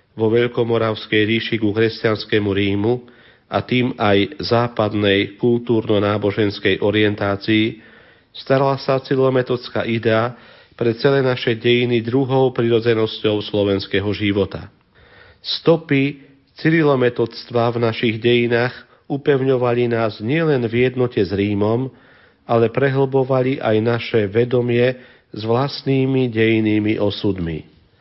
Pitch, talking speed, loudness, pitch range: 115 Hz, 95 wpm, -18 LUFS, 105-125 Hz